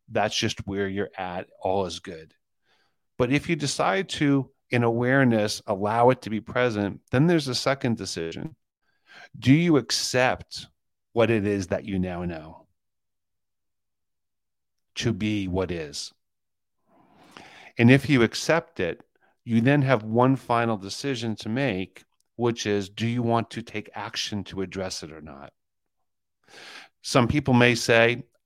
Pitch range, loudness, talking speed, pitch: 95-125 Hz, -24 LUFS, 145 wpm, 110 Hz